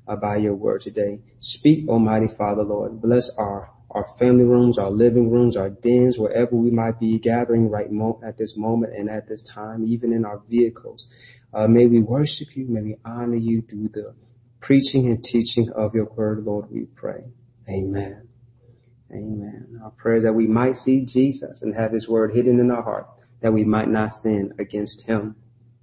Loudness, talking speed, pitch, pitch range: -21 LUFS, 190 wpm, 115 Hz, 110-120 Hz